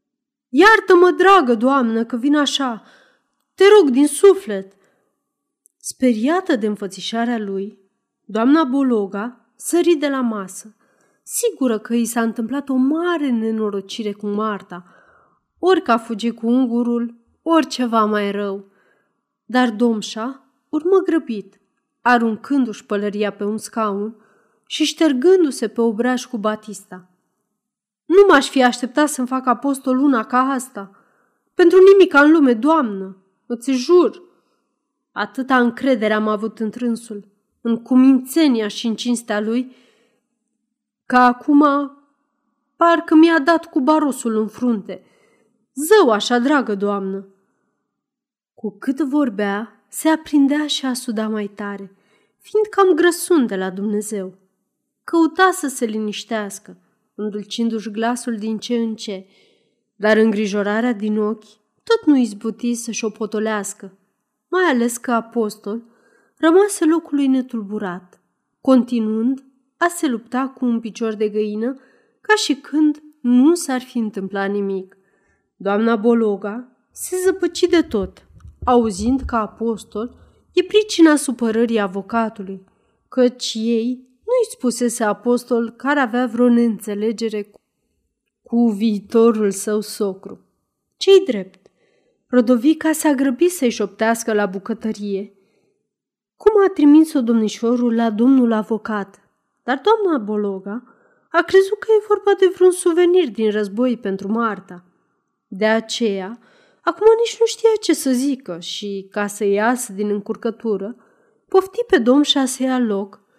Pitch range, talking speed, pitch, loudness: 215-285 Hz, 125 wpm, 235 Hz, -18 LUFS